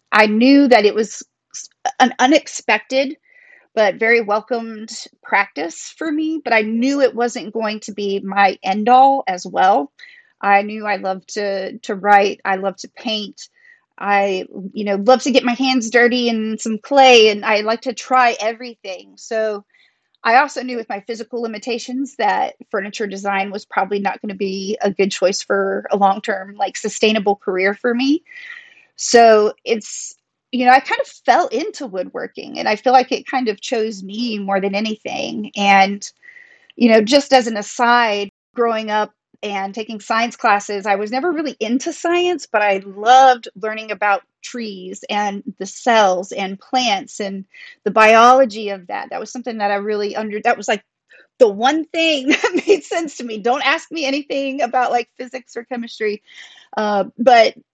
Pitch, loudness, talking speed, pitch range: 225 Hz, -17 LUFS, 175 wpm, 205-255 Hz